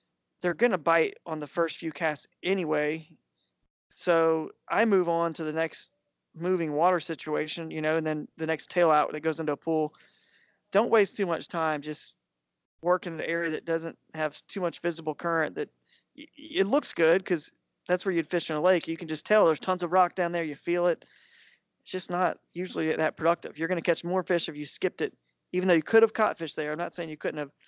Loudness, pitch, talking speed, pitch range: -28 LUFS, 165 Hz, 230 wpm, 155-180 Hz